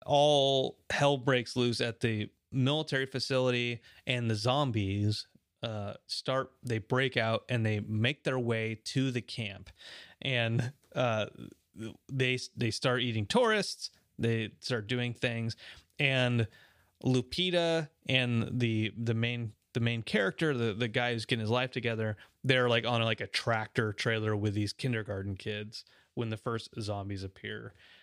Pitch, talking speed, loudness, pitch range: 120 Hz, 145 wpm, -32 LUFS, 110-130 Hz